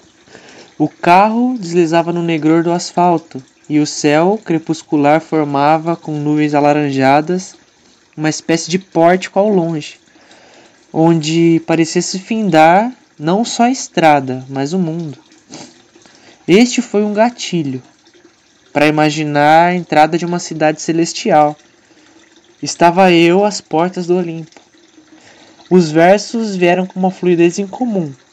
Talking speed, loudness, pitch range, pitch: 120 wpm, -13 LUFS, 155-195 Hz, 170 Hz